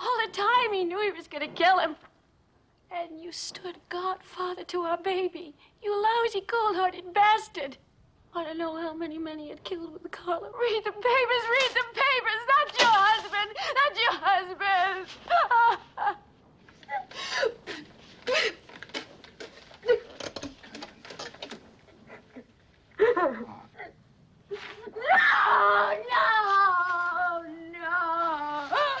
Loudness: -26 LUFS